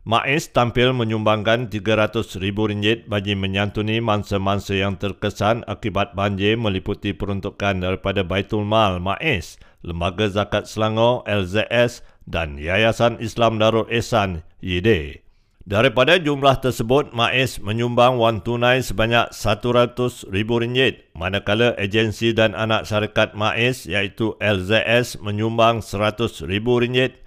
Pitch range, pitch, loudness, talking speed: 100-115 Hz, 110 Hz, -20 LUFS, 100 wpm